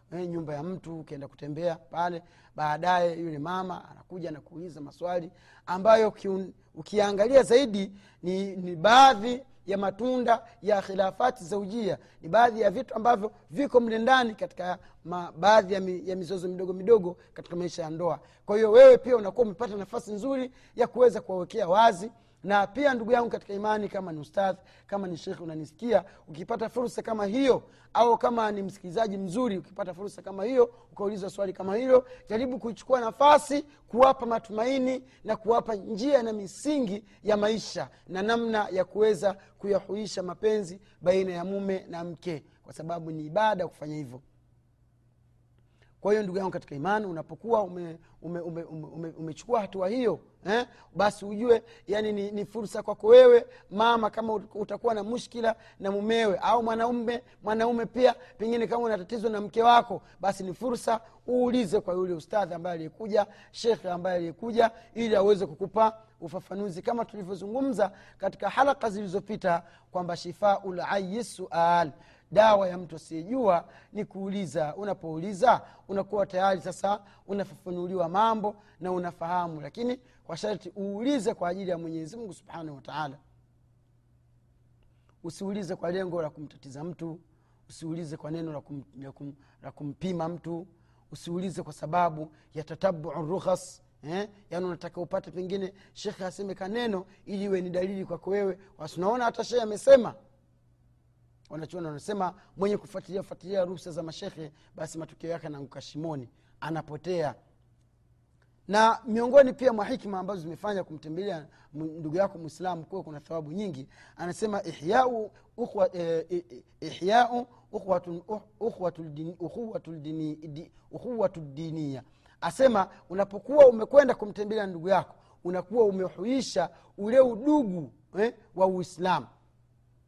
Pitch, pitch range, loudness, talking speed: 190 Hz, 165-220 Hz, -27 LUFS, 130 wpm